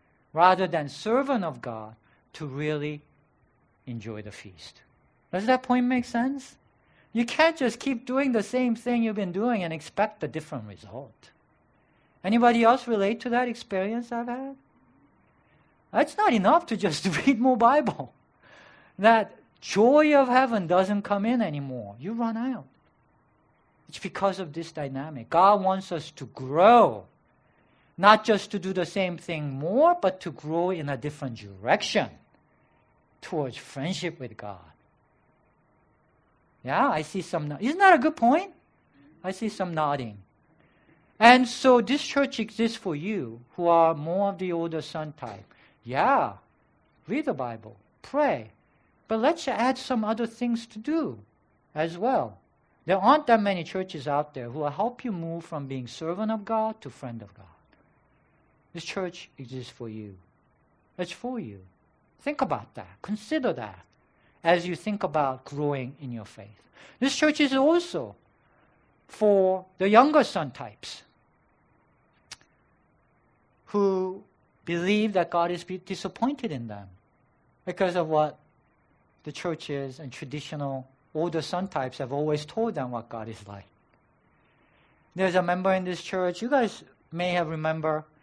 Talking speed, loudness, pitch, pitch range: 150 wpm, -26 LUFS, 180 Hz, 140-225 Hz